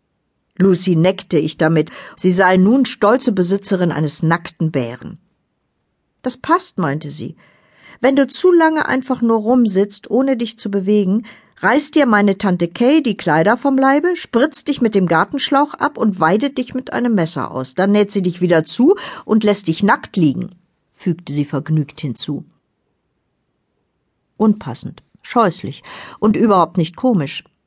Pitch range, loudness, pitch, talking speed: 165-250 Hz, -16 LUFS, 200 Hz, 150 wpm